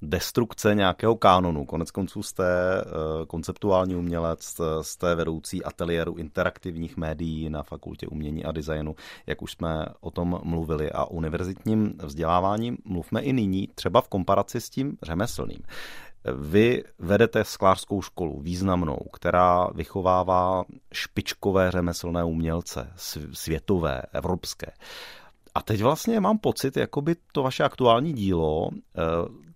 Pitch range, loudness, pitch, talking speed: 80-100 Hz, -26 LUFS, 90 Hz, 120 wpm